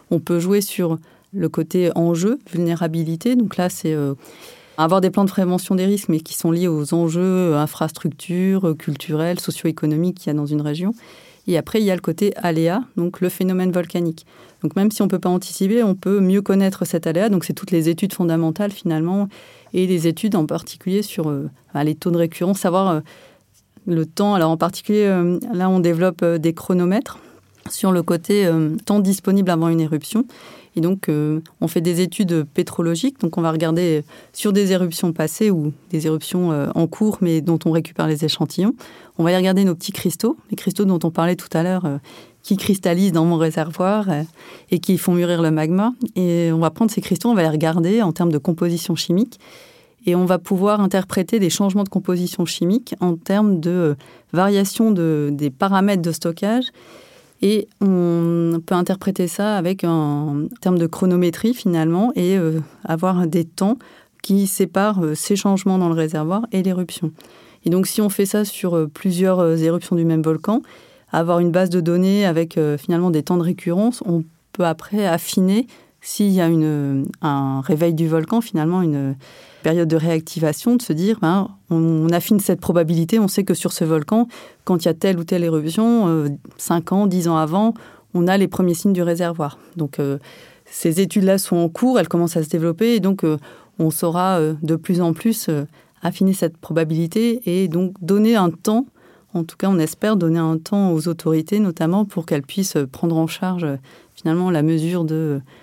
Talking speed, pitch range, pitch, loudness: 190 wpm, 165-195 Hz, 175 Hz, -19 LUFS